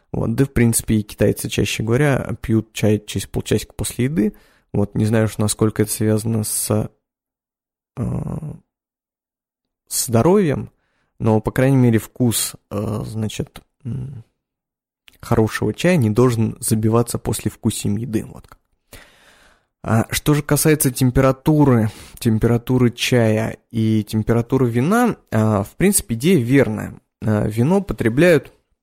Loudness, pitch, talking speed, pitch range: -18 LUFS, 115 Hz, 120 wpm, 110-130 Hz